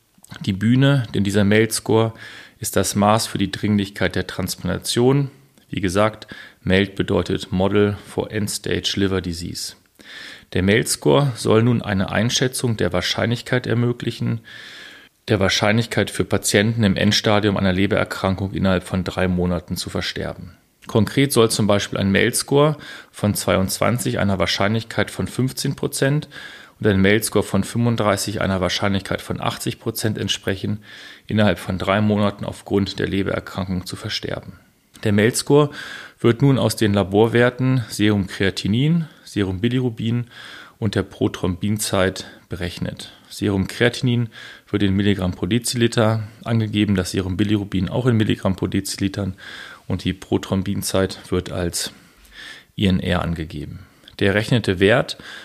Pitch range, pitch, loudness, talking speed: 95-115 Hz, 105 Hz, -20 LUFS, 125 wpm